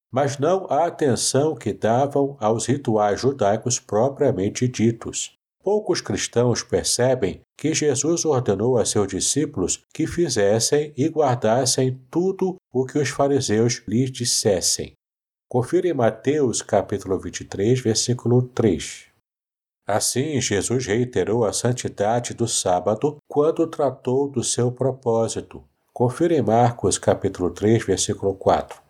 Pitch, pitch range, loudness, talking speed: 125 Hz, 110-145 Hz, -21 LUFS, 120 wpm